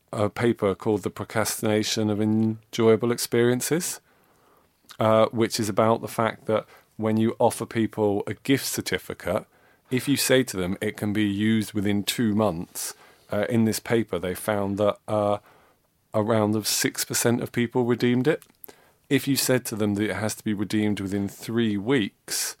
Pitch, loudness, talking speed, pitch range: 110 Hz, -25 LUFS, 165 wpm, 105-120 Hz